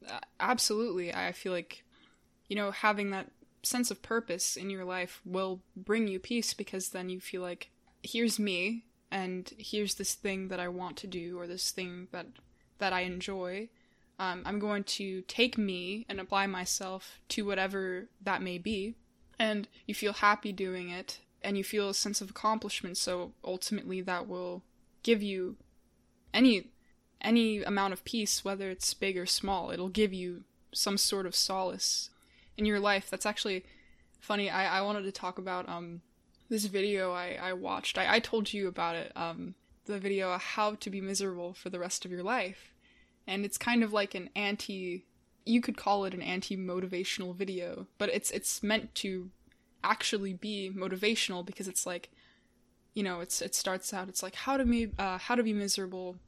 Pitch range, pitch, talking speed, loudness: 185-210 Hz, 195 Hz, 180 wpm, -33 LUFS